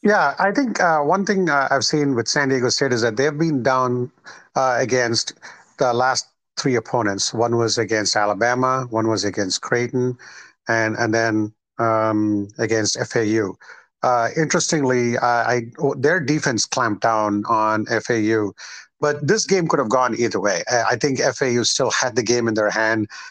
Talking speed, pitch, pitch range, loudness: 175 wpm, 120 Hz, 110-135 Hz, -19 LUFS